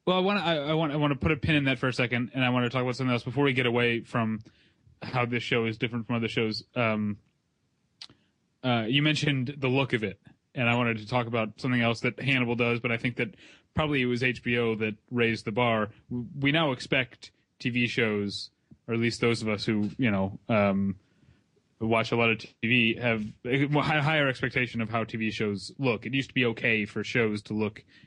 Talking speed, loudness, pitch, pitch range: 225 wpm, -27 LUFS, 120 Hz, 110-130 Hz